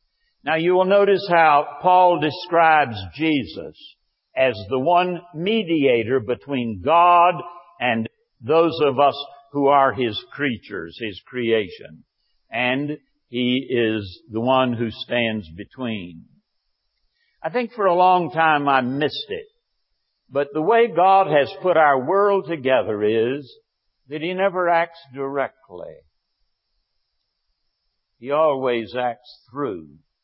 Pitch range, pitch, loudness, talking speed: 125-175 Hz, 145 Hz, -20 LUFS, 120 wpm